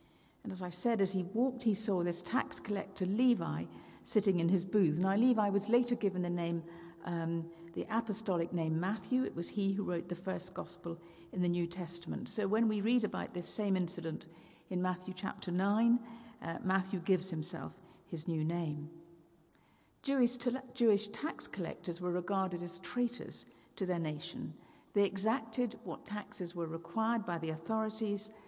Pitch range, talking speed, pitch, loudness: 170-220 Hz, 170 wpm, 190 Hz, -35 LUFS